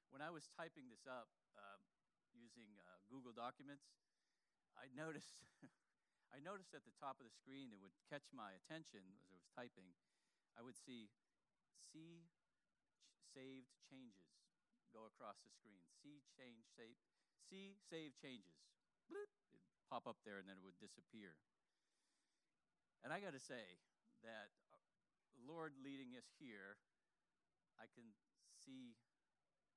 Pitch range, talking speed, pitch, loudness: 115-160 Hz, 140 wpm, 130 Hz, -60 LUFS